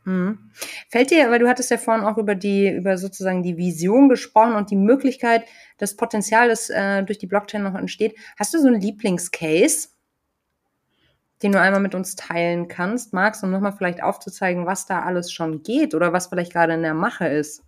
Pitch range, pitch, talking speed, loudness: 180-225 Hz, 200 Hz, 195 wpm, -20 LUFS